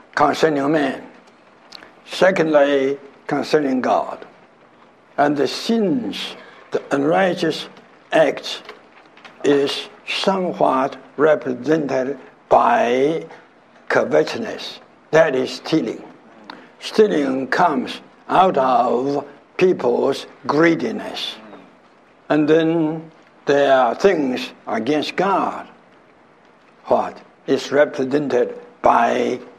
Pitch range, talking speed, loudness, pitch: 135-160 Hz, 75 wpm, -19 LUFS, 145 Hz